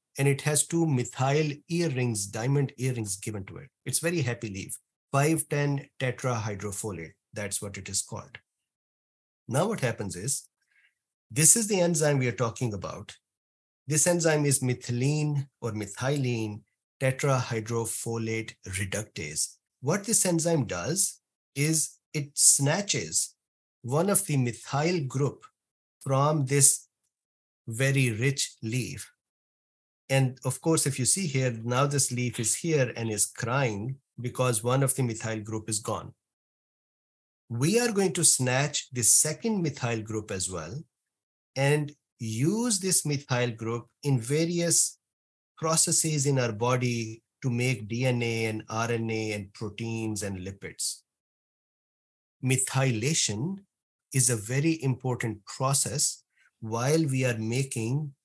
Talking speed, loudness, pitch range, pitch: 125 wpm, -27 LUFS, 115-150 Hz, 130 Hz